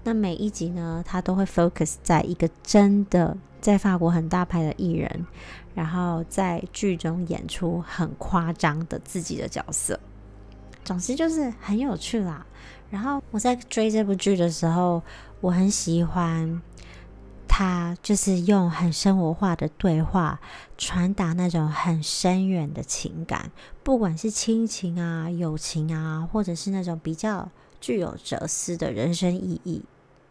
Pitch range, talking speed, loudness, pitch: 165-195 Hz, 220 characters per minute, -25 LUFS, 175 Hz